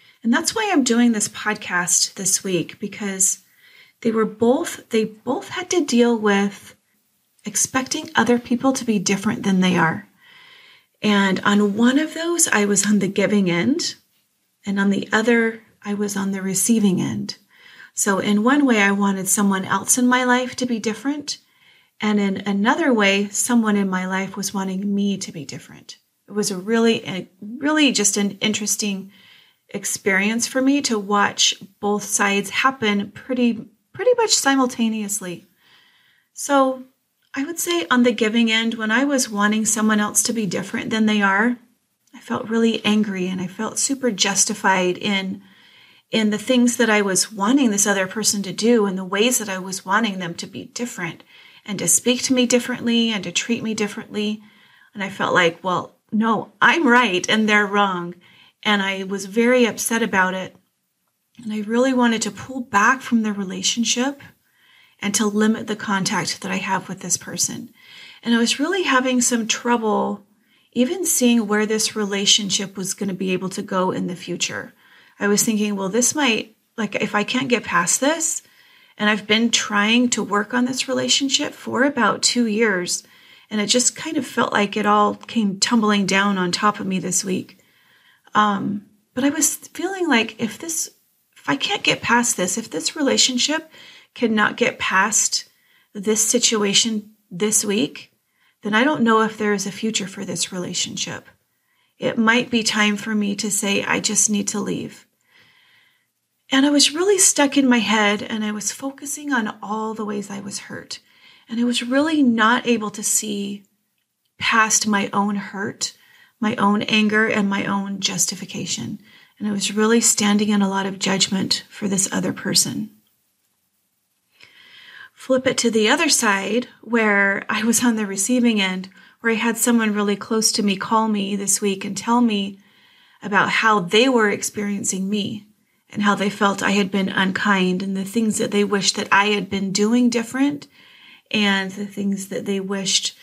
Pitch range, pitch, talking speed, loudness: 200-245 Hz, 215 Hz, 180 wpm, -19 LUFS